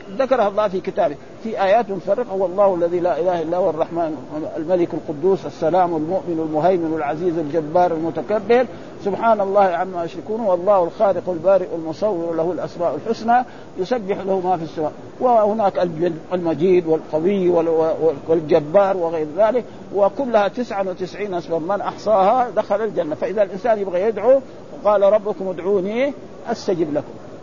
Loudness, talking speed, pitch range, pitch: -19 LUFS, 130 wpm, 170-210 Hz, 185 Hz